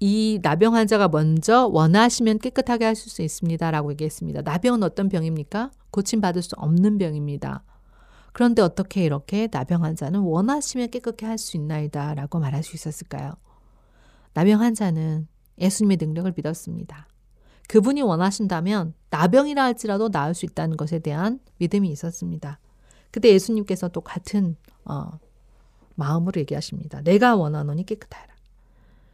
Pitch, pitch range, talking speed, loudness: 175 Hz, 155-215 Hz, 350 characters per minute, -22 LUFS